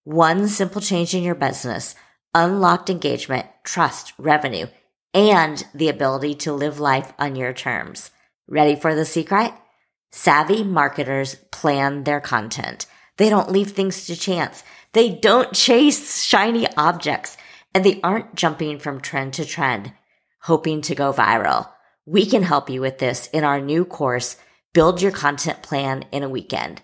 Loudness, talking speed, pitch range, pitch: -19 LUFS, 150 wpm, 140-190 Hz, 155 Hz